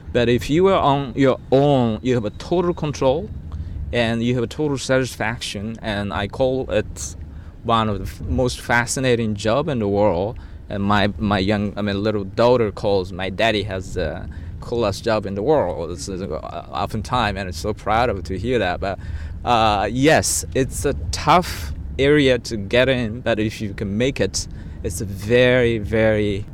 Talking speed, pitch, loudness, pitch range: 190 wpm, 105 Hz, -20 LUFS, 95-120 Hz